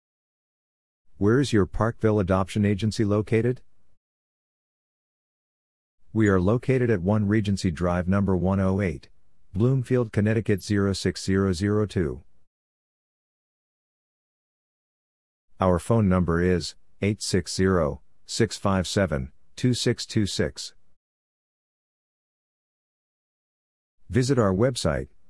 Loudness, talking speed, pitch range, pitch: -24 LUFS, 65 wpm, 90-110 Hz, 95 Hz